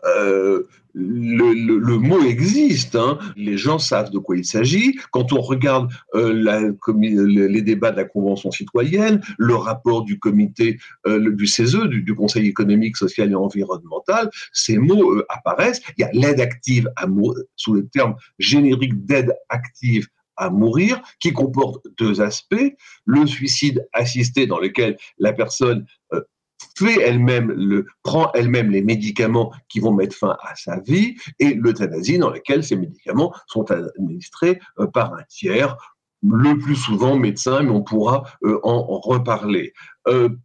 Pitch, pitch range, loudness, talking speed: 120 Hz, 105-135 Hz, -18 LUFS, 155 wpm